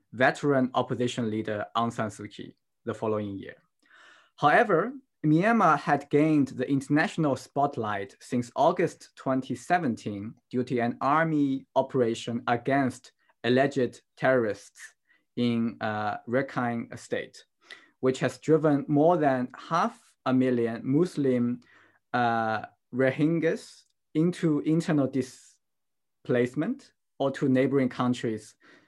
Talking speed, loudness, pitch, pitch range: 105 wpm, -27 LUFS, 130 Hz, 120-145 Hz